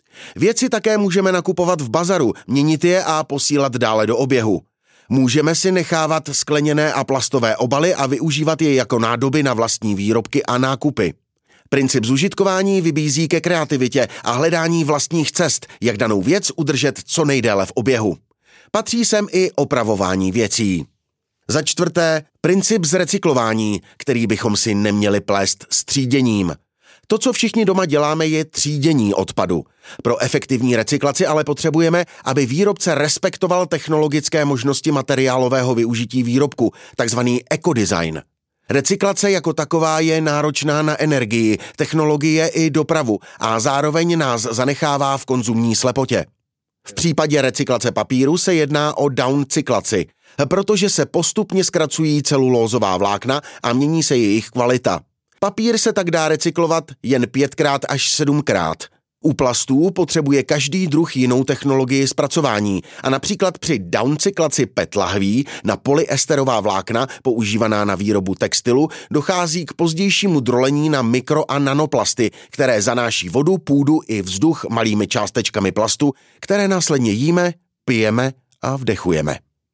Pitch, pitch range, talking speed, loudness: 145 Hz, 125-160 Hz, 130 wpm, -17 LUFS